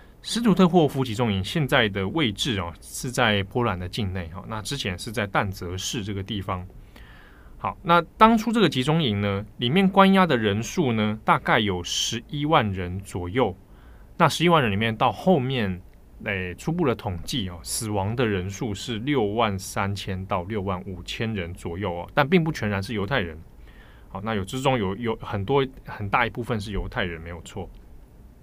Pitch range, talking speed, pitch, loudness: 95-130 Hz, 280 characters per minute, 105 Hz, -24 LUFS